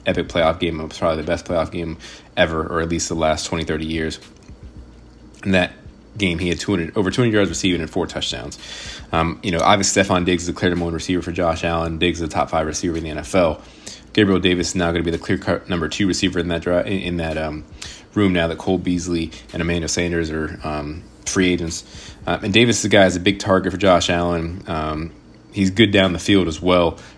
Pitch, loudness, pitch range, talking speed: 85 Hz, -19 LUFS, 80-95 Hz, 230 wpm